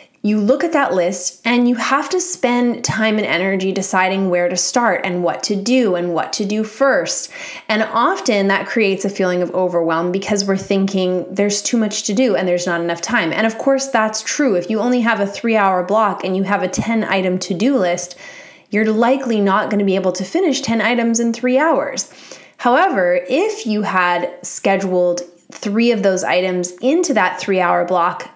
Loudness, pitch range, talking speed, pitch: -16 LUFS, 185-240 Hz, 205 wpm, 205 Hz